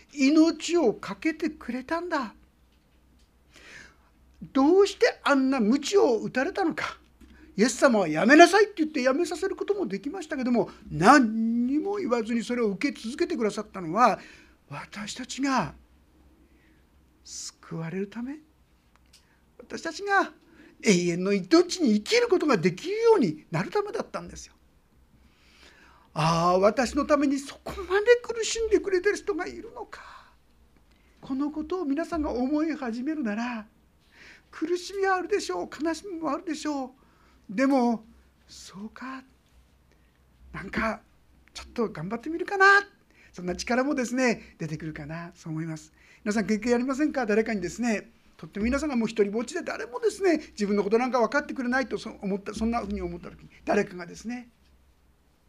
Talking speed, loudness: 320 characters per minute, -26 LUFS